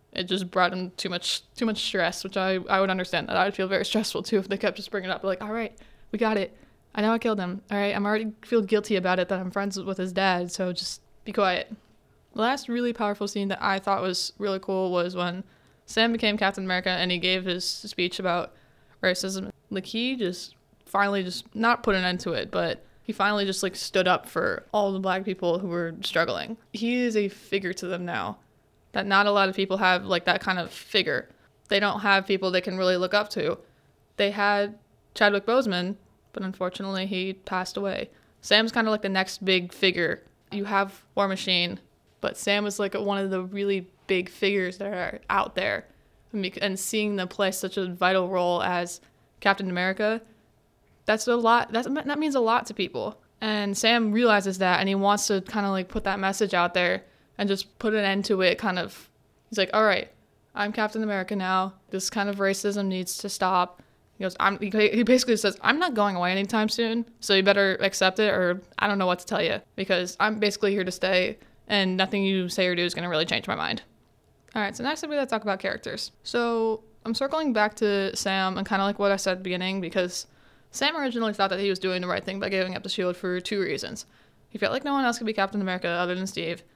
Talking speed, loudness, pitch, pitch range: 230 wpm, -26 LUFS, 195 Hz, 185-210 Hz